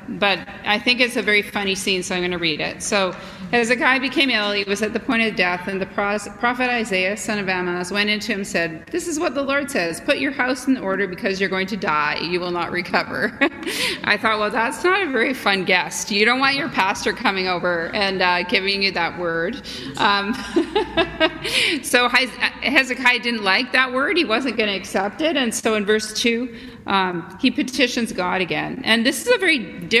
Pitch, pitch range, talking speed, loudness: 215 Hz, 190-255 Hz, 220 wpm, -19 LUFS